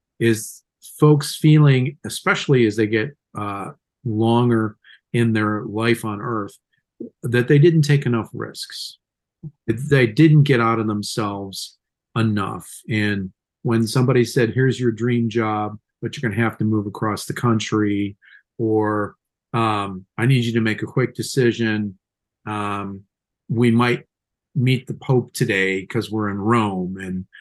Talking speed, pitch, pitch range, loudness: 145 wpm, 115 Hz, 105-125 Hz, -20 LUFS